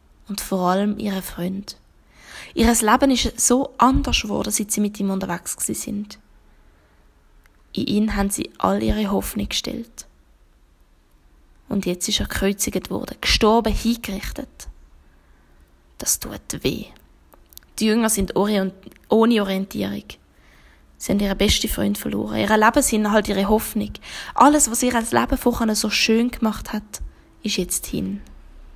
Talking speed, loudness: 140 wpm, -21 LUFS